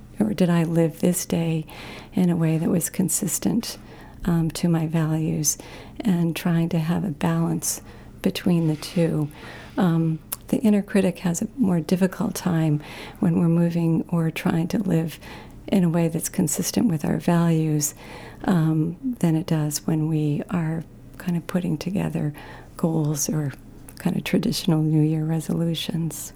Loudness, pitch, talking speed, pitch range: -23 LUFS, 165 Hz, 155 wpm, 155-180 Hz